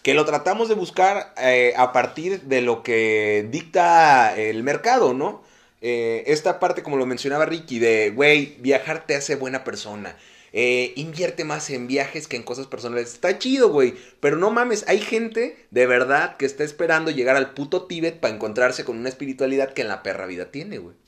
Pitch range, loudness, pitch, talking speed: 125-175 Hz, -21 LUFS, 140 Hz, 190 wpm